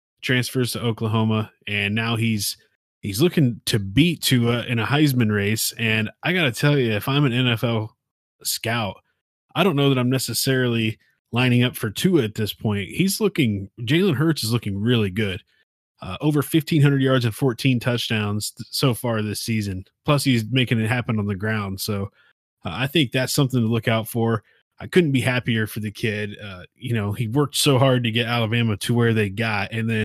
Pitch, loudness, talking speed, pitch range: 120 Hz, -21 LUFS, 200 wpm, 110-135 Hz